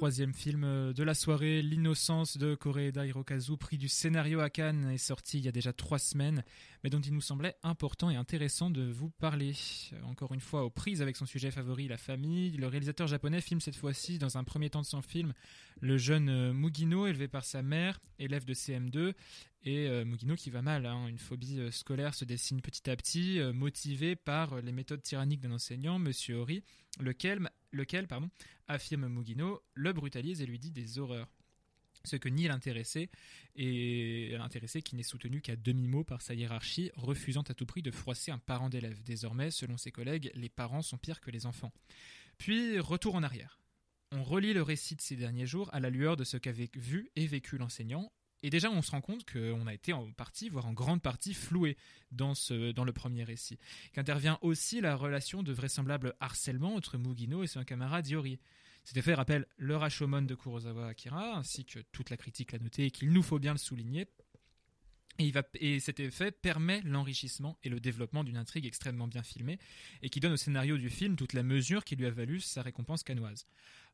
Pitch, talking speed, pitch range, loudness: 140 Hz, 200 wpm, 125-155 Hz, -36 LUFS